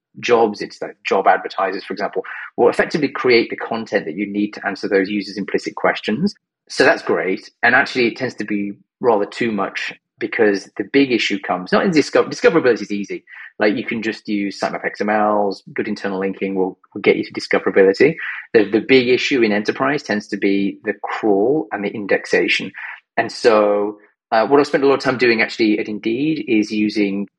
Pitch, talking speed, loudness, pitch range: 105 Hz, 195 wpm, -18 LUFS, 100-125 Hz